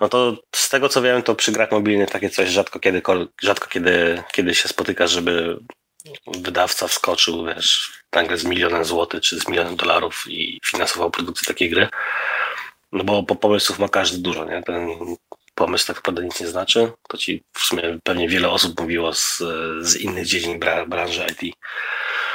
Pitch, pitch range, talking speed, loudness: 90 Hz, 85-105 Hz, 175 wpm, -19 LUFS